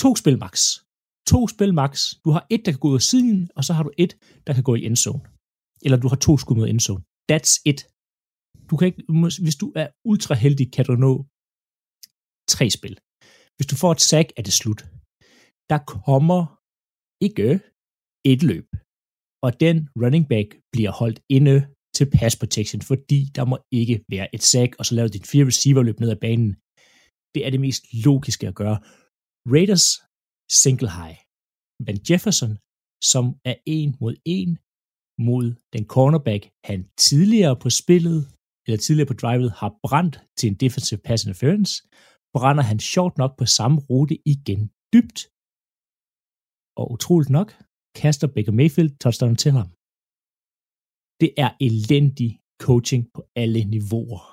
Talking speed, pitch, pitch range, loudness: 160 wpm, 130 Hz, 110-155 Hz, -20 LUFS